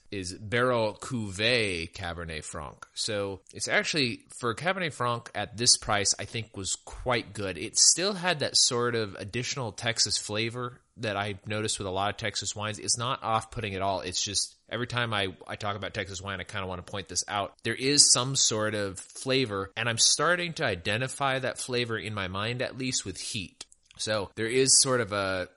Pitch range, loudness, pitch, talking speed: 95-125 Hz, -27 LUFS, 110 Hz, 205 wpm